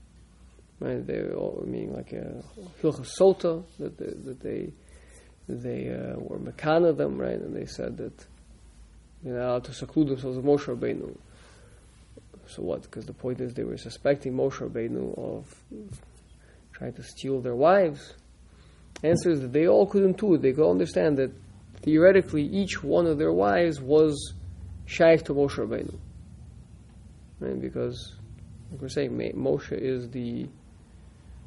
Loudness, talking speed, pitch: -26 LUFS, 150 wpm, 130 Hz